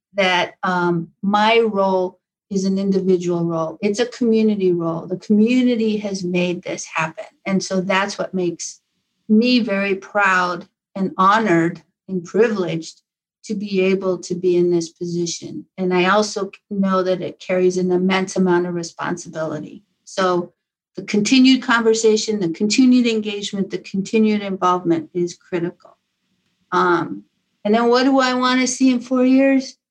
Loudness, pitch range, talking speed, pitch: -18 LUFS, 180-215 Hz, 145 wpm, 190 Hz